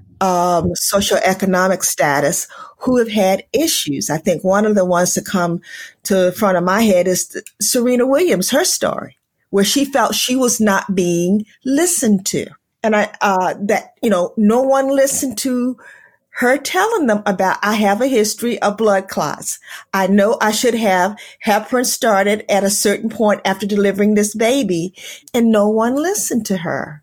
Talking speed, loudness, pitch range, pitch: 175 wpm, -16 LUFS, 190-245 Hz, 205 Hz